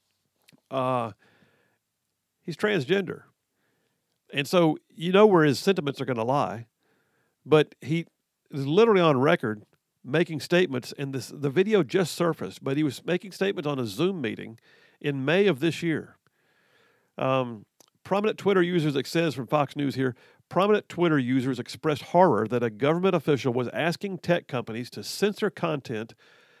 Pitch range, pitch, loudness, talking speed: 130-175 Hz, 150 Hz, -25 LUFS, 150 wpm